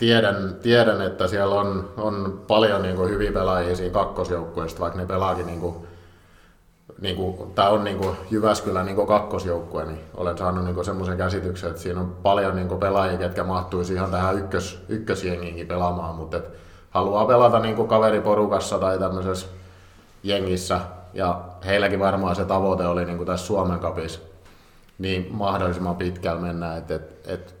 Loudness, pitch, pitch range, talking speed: -23 LUFS, 95 Hz, 90-100 Hz, 150 wpm